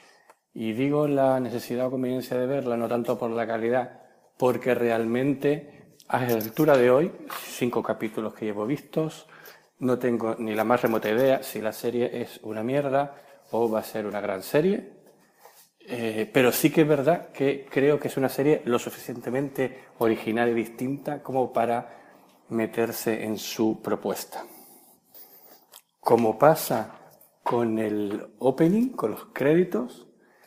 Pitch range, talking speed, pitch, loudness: 115-140 Hz, 150 wpm, 125 Hz, -26 LUFS